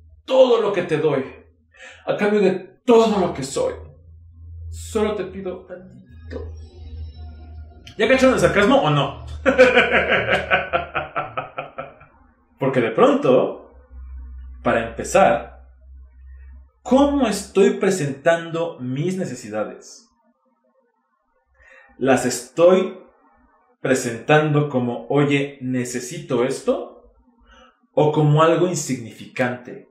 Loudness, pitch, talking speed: -19 LUFS, 135 Hz, 85 wpm